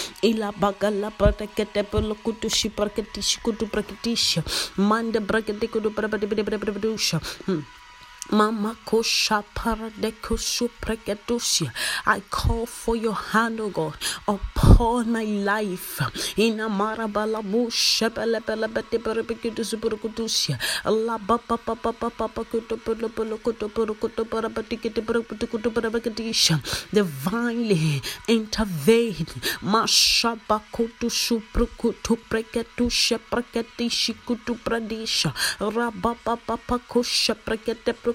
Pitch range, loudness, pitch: 210-230 Hz, -24 LUFS, 225 Hz